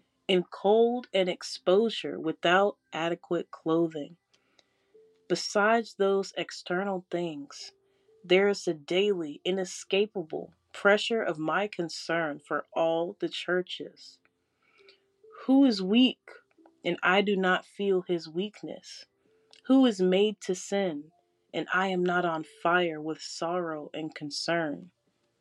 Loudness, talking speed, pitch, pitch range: -28 LUFS, 115 wpm, 185 Hz, 170-210 Hz